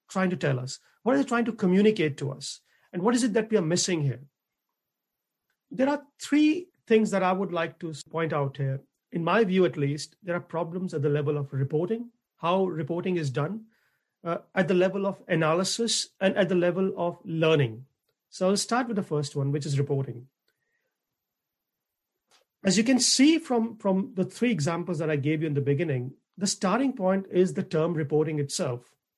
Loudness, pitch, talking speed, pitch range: -26 LUFS, 180 Hz, 195 wpm, 150-210 Hz